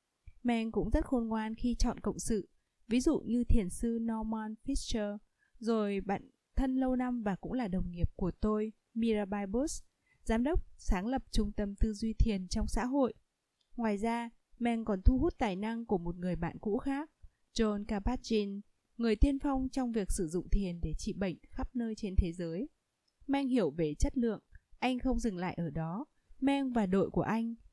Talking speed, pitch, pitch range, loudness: 195 wpm, 225 Hz, 205-250 Hz, -35 LUFS